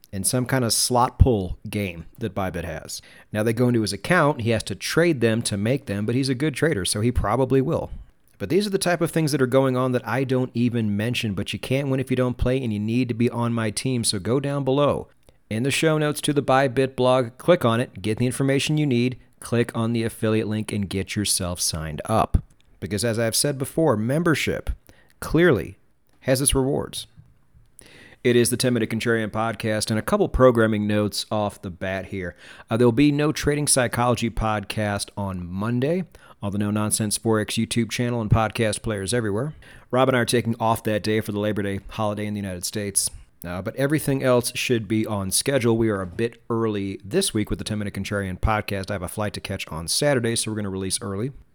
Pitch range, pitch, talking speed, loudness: 105-130 Hz, 115 Hz, 225 wpm, -23 LUFS